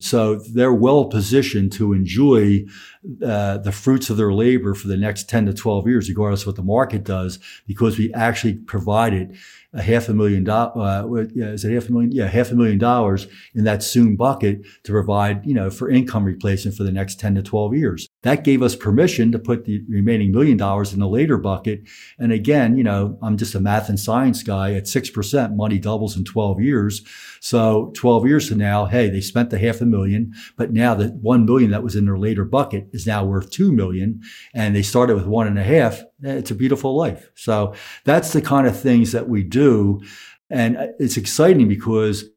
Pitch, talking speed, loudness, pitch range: 110 Hz, 210 wpm, -18 LUFS, 100-120 Hz